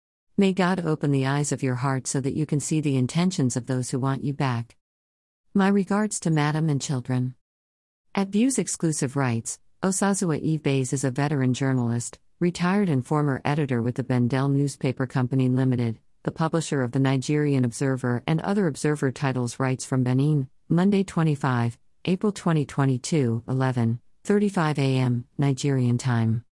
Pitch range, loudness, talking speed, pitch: 125-155 Hz, -25 LUFS, 155 wpm, 140 Hz